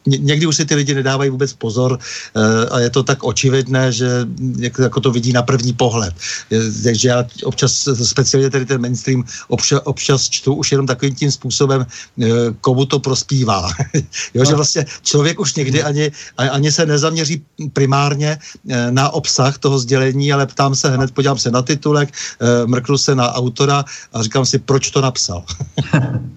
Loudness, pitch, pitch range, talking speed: -15 LUFS, 135 Hz, 125-140 Hz, 170 wpm